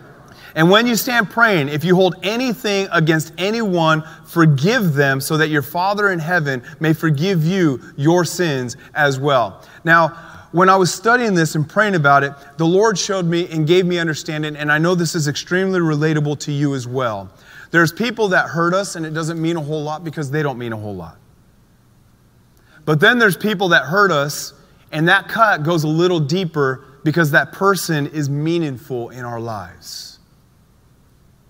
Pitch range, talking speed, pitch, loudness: 145-185 Hz, 185 wpm, 165 Hz, -17 LUFS